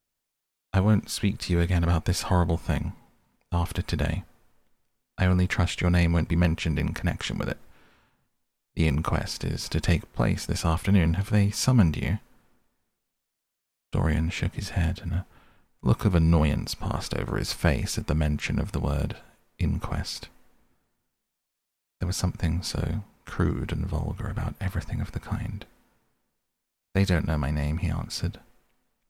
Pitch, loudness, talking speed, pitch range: 90 Hz, -27 LUFS, 155 wpm, 80-100 Hz